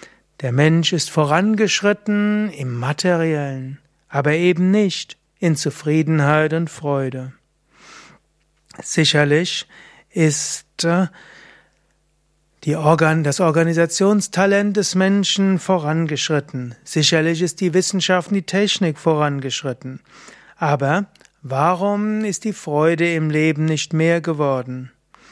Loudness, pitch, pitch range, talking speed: -18 LUFS, 160 Hz, 150-185 Hz, 95 wpm